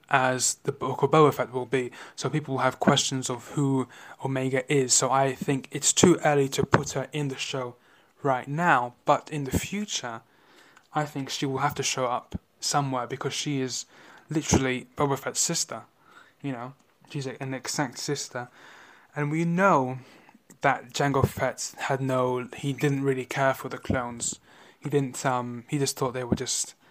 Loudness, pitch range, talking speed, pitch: -26 LUFS, 130-145 Hz, 180 wpm, 135 Hz